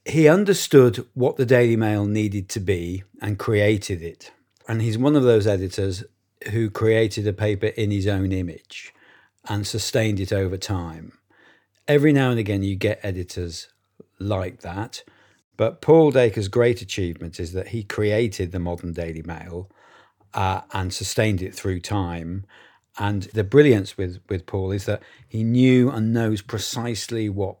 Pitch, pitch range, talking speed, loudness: 105 Hz, 95-115 Hz, 160 wpm, -22 LUFS